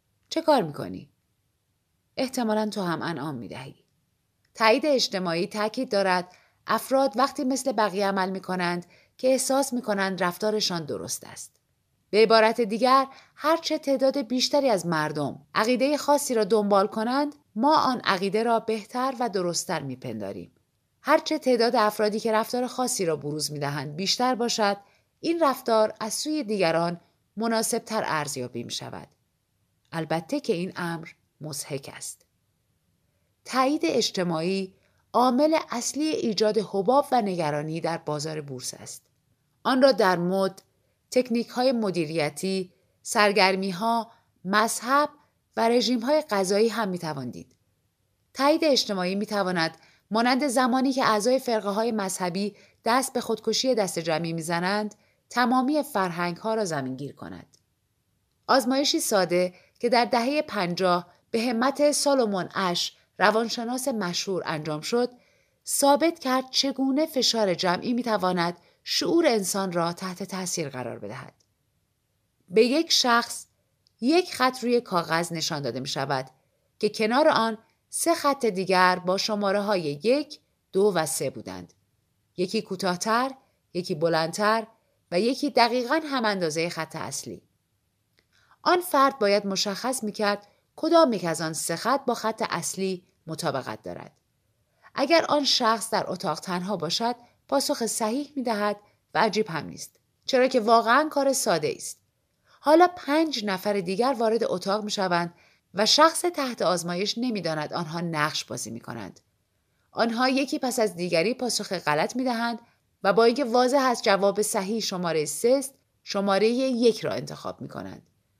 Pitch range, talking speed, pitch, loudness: 170-250 Hz, 135 wpm, 210 Hz, -25 LUFS